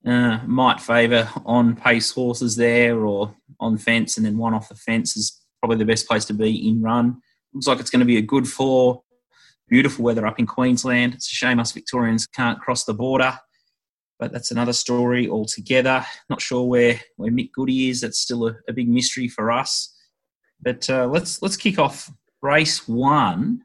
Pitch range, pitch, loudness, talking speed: 115-130 Hz, 120 Hz, -20 LUFS, 195 wpm